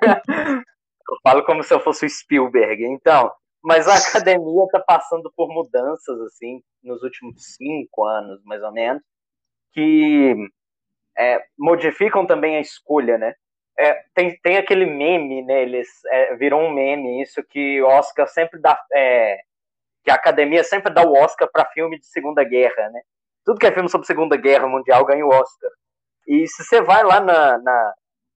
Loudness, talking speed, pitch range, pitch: -17 LUFS, 165 wpm, 130-185 Hz, 150 Hz